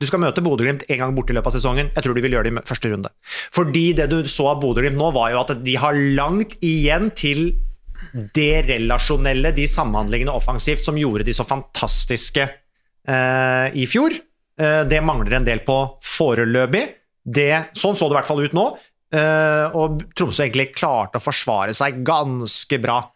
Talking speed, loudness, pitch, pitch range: 190 wpm, -19 LUFS, 140 Hz, 125-155 Hz